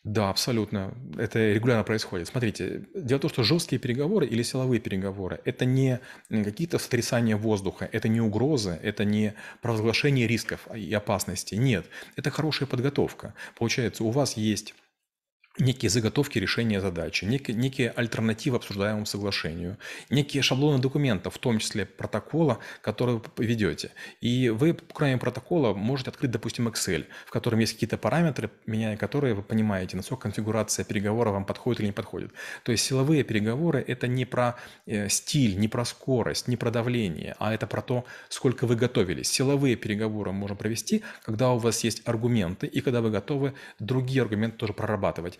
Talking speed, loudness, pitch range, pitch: 155 wpm, -27 LUFS, 105-130 Hz, 115 Hz